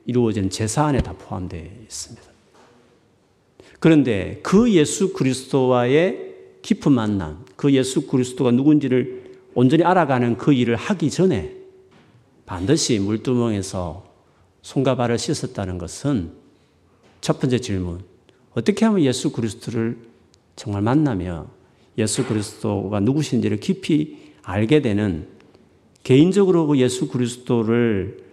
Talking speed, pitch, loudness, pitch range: 275 characters per minute, 120 Hz, -20 LUFS, 100-150 Hz